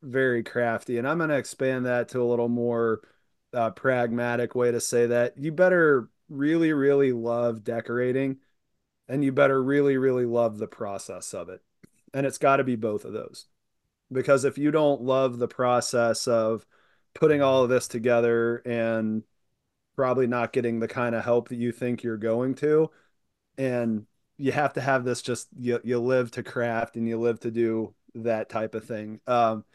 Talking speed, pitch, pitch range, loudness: 185 wpm, 120 Hz, 115-130 Hz, -25 LUFS